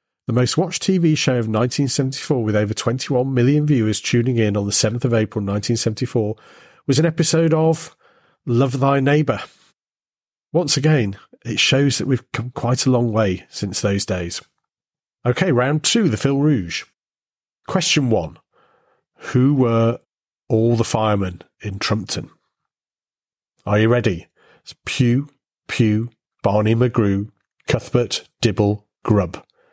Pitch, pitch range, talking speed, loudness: 120 Hz, 110-140 Hz, 145 wpm, -19 LUFS